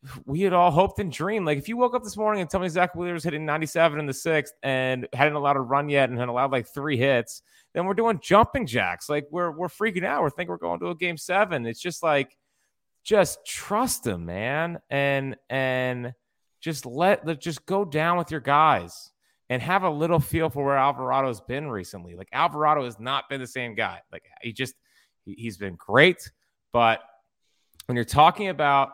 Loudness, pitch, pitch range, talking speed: -24 LUFS, 145 Hz, 130-175 Hz, 210 wpm